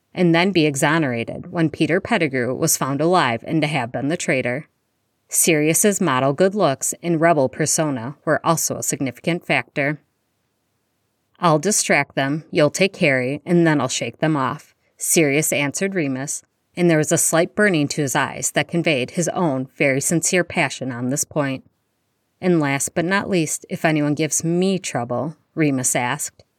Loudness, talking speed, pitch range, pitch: -19 LUFS, 165 wpm, 140-170 Hz, 155 Hz